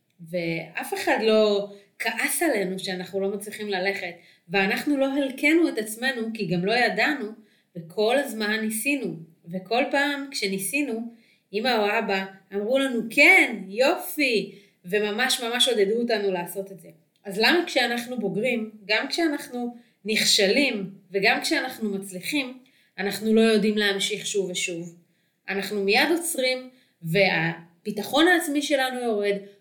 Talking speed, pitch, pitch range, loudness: 125 wpm, 215 Hz, 195-255 Hz, -23 LUFS